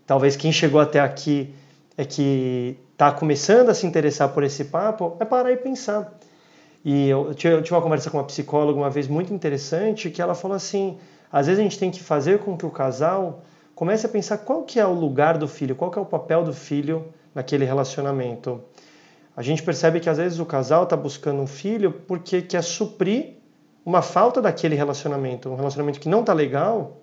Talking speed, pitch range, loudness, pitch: 200 wpm, 145-185 Hz, -22 LUFS, 160 Hz